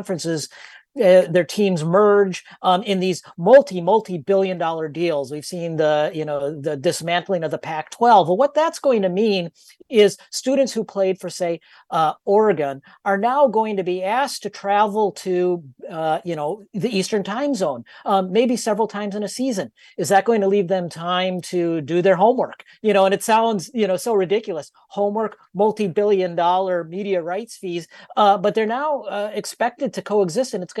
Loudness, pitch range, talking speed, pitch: -20 LUFS, 175-215 Hz, 185 wpm, 195 Hz